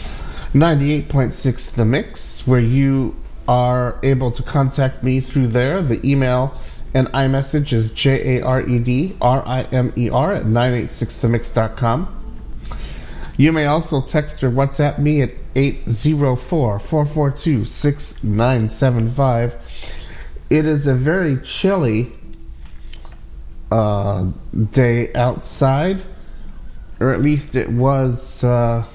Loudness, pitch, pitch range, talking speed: -18 LUFS, 130 Hz, 115-140 Hz, 115 wpm